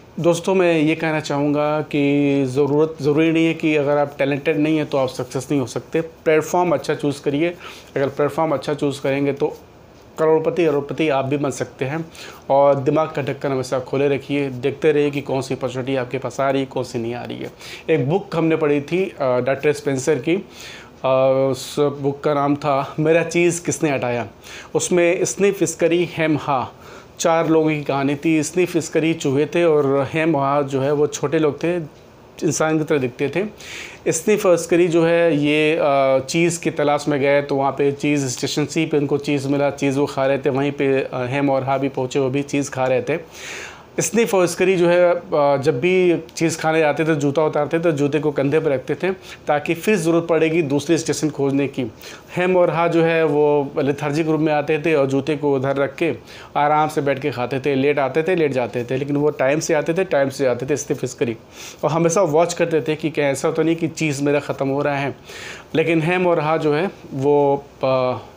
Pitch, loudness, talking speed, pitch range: 150 Hz, -19 LUFS, 210 wpm, 140-160 Hz